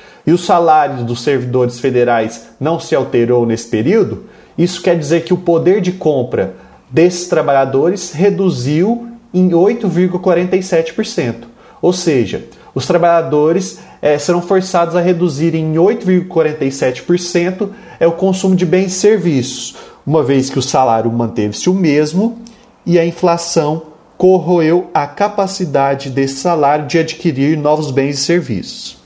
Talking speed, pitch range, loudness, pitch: 130 wpm, 140-180 Hz, -14 LUFS, 170 Hz